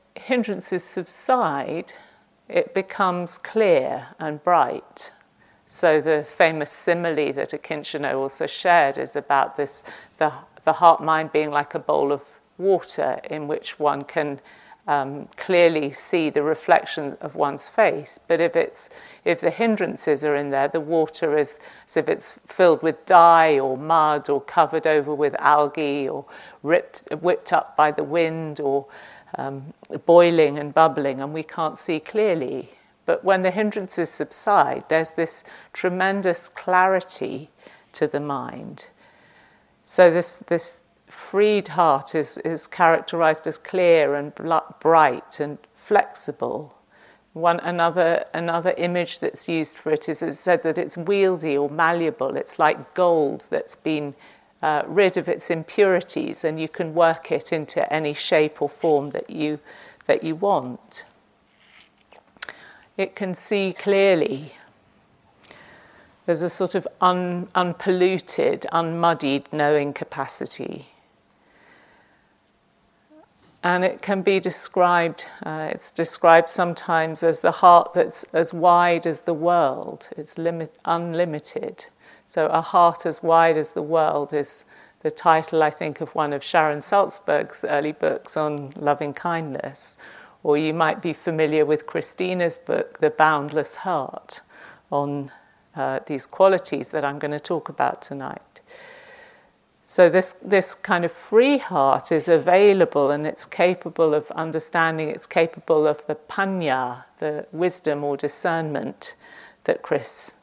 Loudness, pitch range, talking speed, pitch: -21 LUFS, 150-180 Hz, 140 wpm, 165 Hz